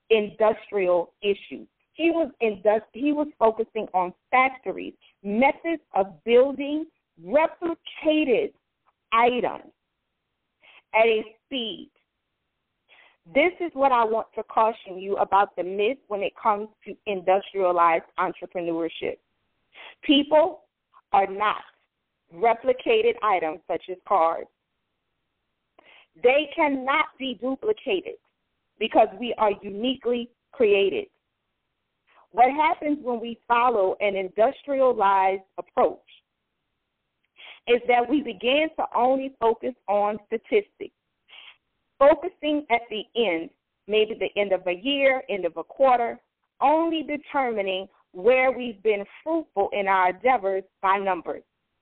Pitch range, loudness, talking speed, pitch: 200-280 Hz, -24 LUFS, 110 wpm, 230 Hz